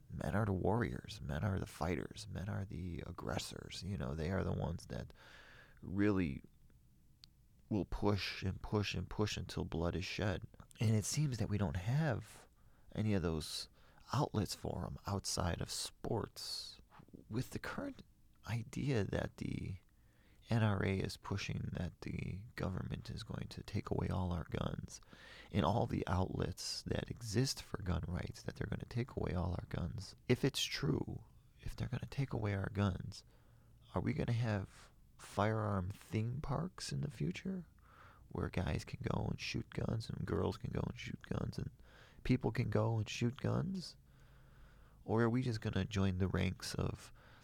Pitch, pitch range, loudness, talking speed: 105 Hz, 95-120 Hz, -40 LUFS, 175 wpm